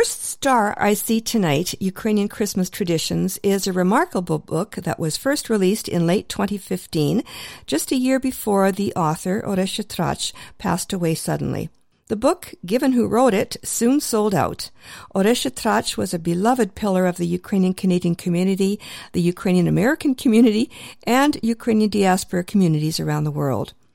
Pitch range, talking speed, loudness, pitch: 180-230 Hz, 155 wpm, -21 LUFS, 200 Hz